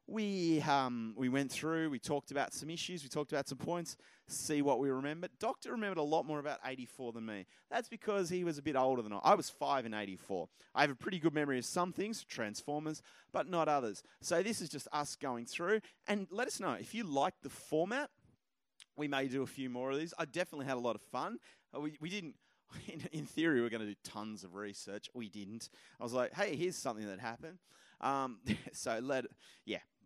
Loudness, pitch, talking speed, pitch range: -38 LUFS, 140 Hz, 230 wpm, 125-170 Hz